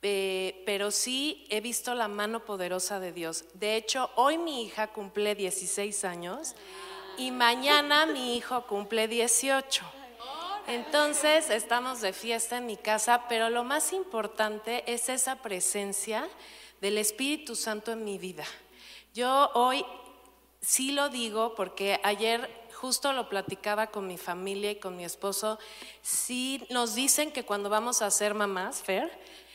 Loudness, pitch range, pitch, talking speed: -29 LUFS, 205-250 Hz, 225 Hz, 145 wpm